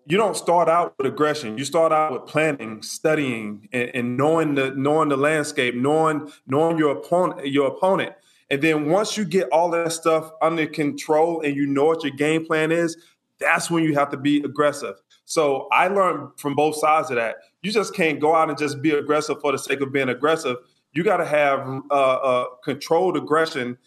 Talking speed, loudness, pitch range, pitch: 205 wpm, -21 LUFS, 140-160 Hz, 150 Hz